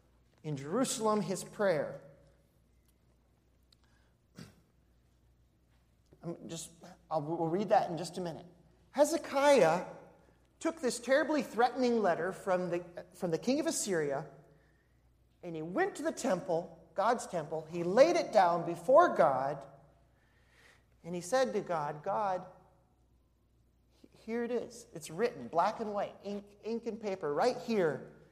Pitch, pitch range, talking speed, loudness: 180 Hz, 155-235 Hz, 130 wpm, -32 LUFS